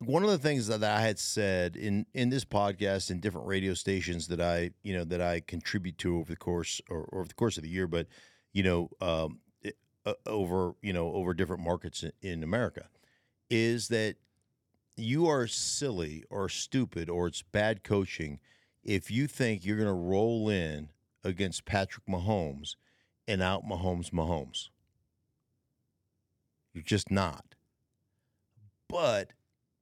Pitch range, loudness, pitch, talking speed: 85-110 Hz, -32 LUFS, 95 Hz, 160 wpm